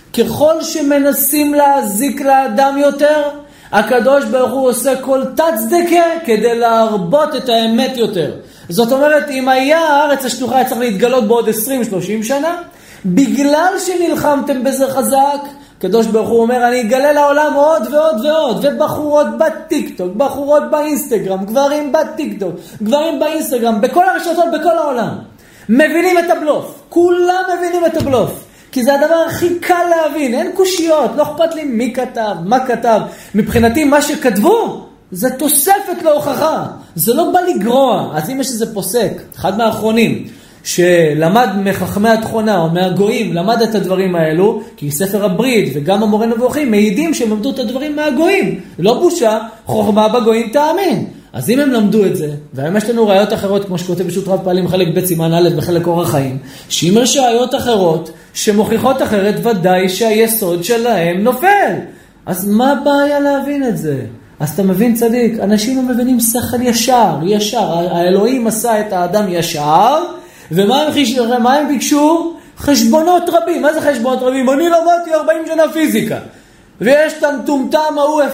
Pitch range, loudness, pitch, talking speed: 215-295 Hz, -13 LUFS, 255 Hz, 145 wpm